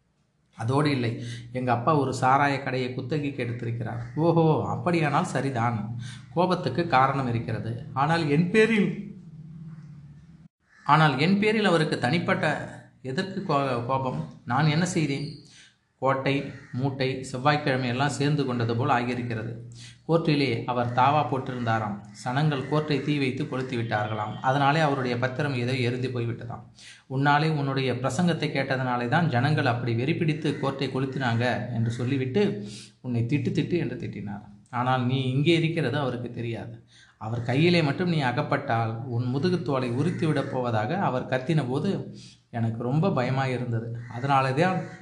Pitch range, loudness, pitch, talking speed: 120-155 Hz, -26 LUFS, 135 Hz, 125 wpm